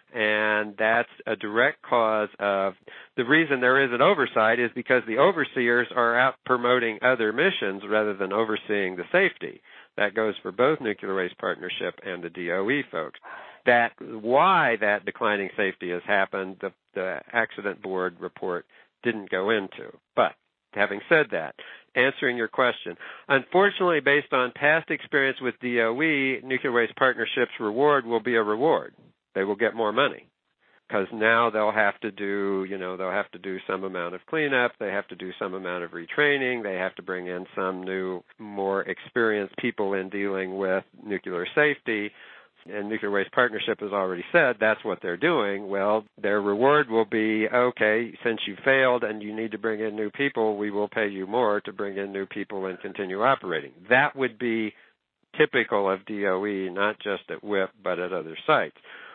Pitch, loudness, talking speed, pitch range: 110 Hz, -25 LUFS, 175 wpm, 100-125 Hz